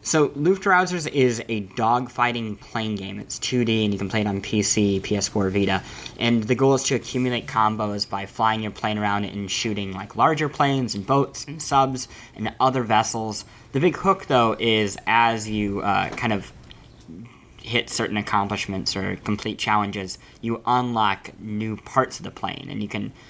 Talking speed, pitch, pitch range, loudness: 175 wpm, 110 Hz, 105-125 Hz, -23 LUFS